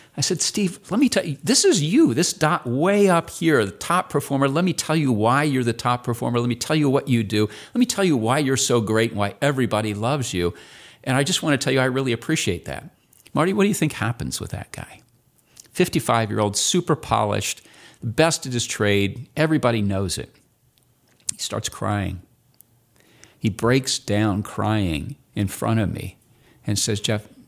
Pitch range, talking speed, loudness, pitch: 110-155 Hz, 200 wpm, -21 LUFS, 125 Hz